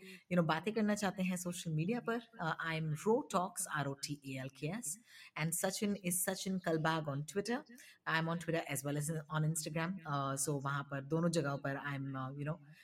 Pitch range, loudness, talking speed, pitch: 145-190 Hz, -38 LUFS, 185 wpm, 165 Hz